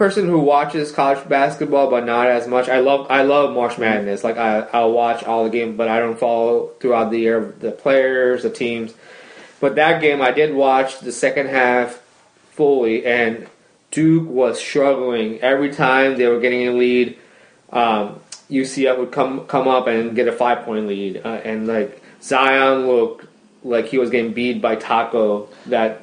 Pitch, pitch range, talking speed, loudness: 125 Hz, 115-135 Hz, 180 wpm, -17 LUFS